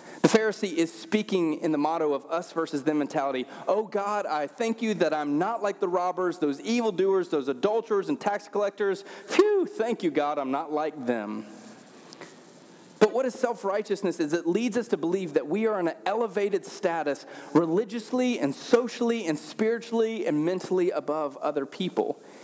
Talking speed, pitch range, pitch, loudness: 175 wpm, 155-225 Hz, 190 Hz, -27 LUFS